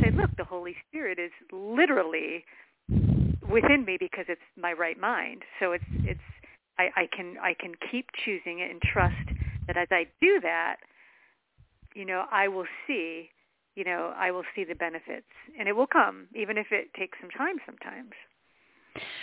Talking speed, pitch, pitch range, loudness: 170 wpm, 185 Hz, 175-210 Hz, -28 LUFS